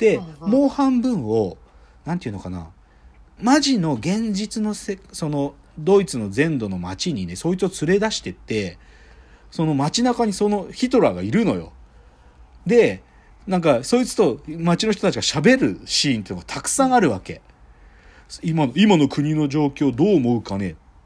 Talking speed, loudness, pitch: 310 characters per minute, -20 LUFS, 155 Hz